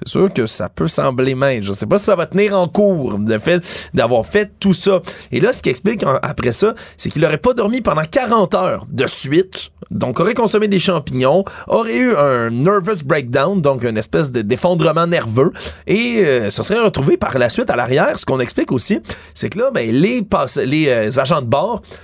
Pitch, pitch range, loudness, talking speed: 185 Hz, 135-205 Hz, -15 LUFS, 220 wpm